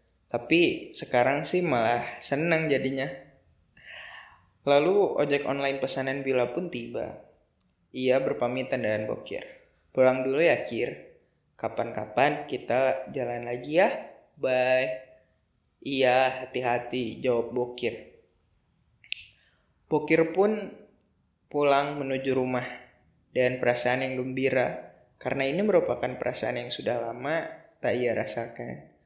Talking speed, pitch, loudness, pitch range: 105 wpm, 130 Hz, -27 LUFS, 125-140 Hz